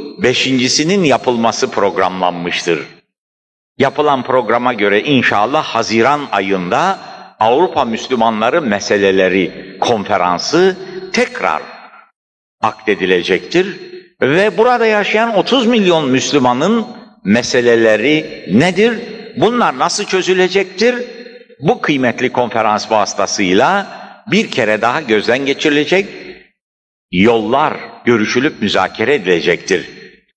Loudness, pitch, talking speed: -13 LUFS, 135 Hz, 75 wpm